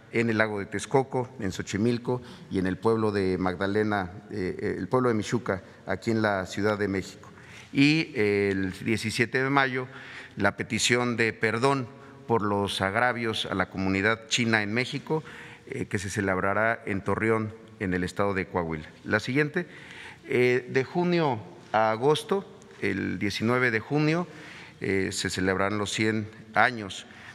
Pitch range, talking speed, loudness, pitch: 100-130 Hz, 145 wpm, -27 LUFS, 110 Hz